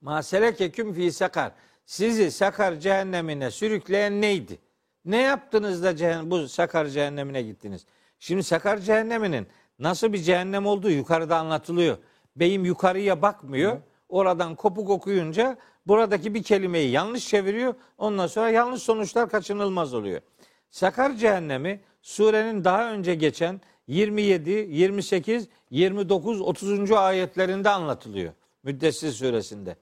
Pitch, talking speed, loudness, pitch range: 190 Hz, 105 wpm, -24 LUFS, 170-210 Hz